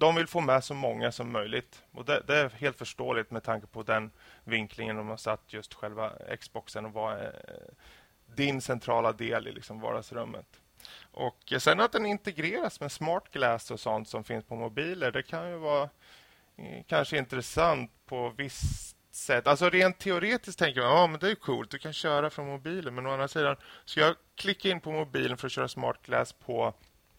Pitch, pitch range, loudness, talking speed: 140 Hz, 115-170 Hz, -30 LUFS, 185 wpm